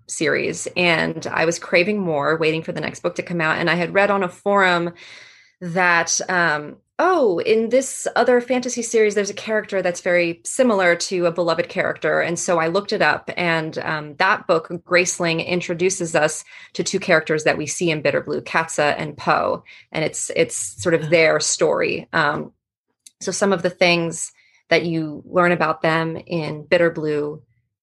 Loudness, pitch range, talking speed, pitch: -19 LUFS, 160-190 Hz, 185 wpm, 175 Hz